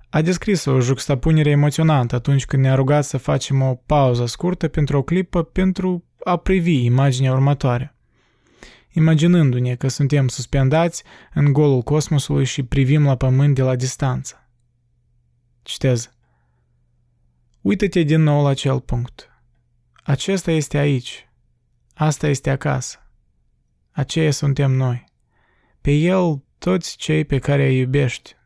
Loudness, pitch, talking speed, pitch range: -18 LUFS, 140 Hz, 125 wpm, 130-155 Hz